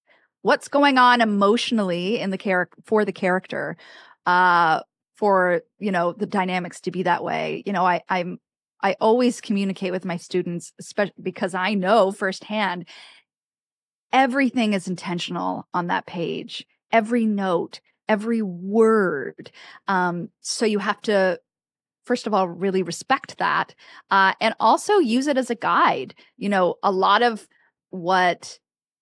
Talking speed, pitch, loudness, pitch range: 145 wpm, 195 Hz, -22 LUFS, 180-225 Hz